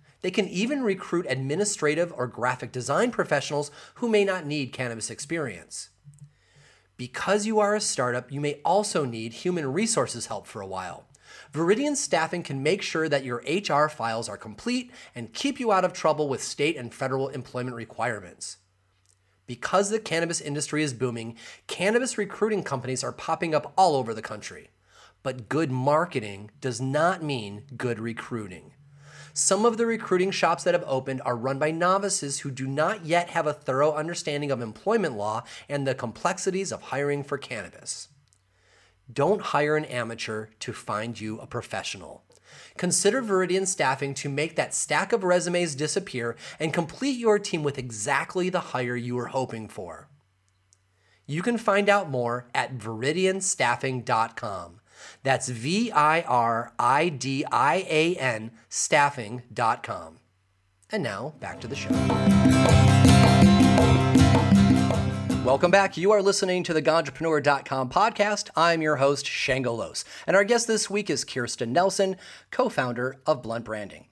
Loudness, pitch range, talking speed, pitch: -25 LUFS, 120-175 Hz, 145 wpm, 140 Hz